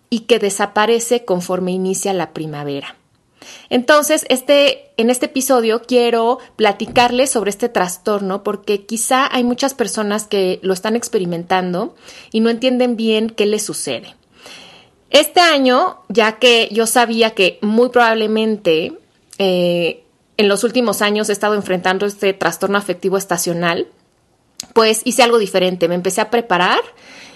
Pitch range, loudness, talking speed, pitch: 190-245 Hz, -15 LUFS, 135 wpm, 220 Hz